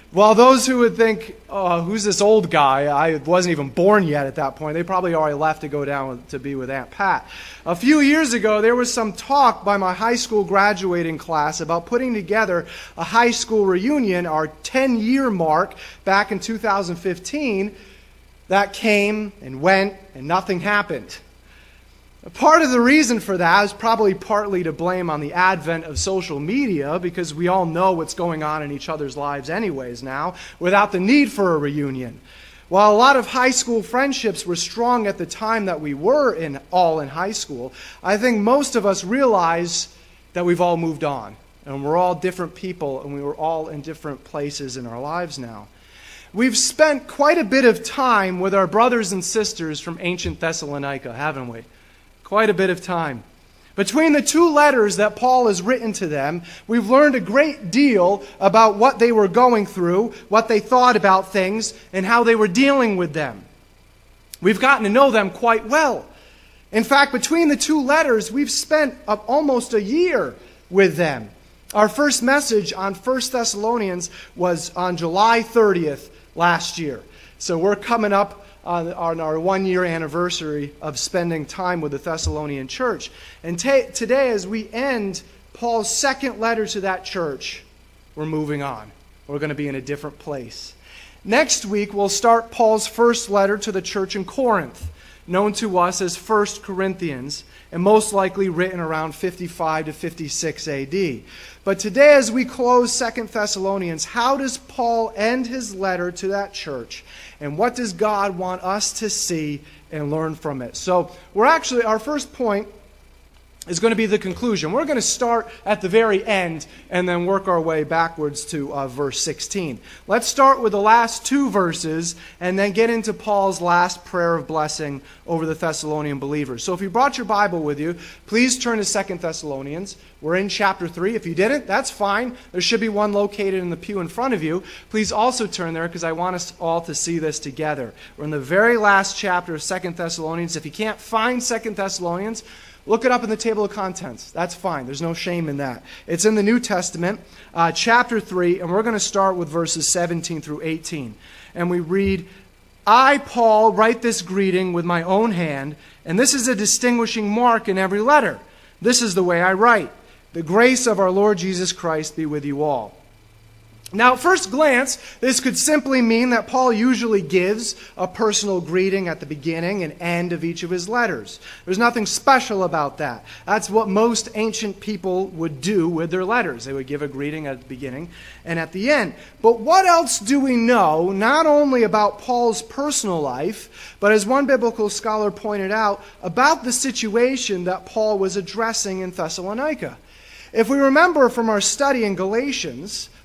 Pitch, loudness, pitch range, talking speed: 195 Hz, -19 LUFS, 165-230 Hz, 185 wpm